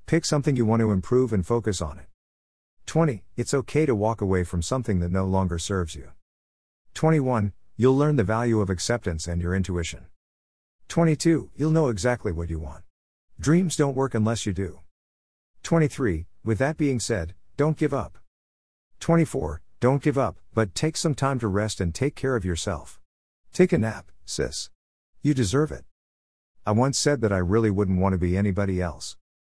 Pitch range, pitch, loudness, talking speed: 85-130 Hz, 100 Hz, -25 LUFS, 180 wpm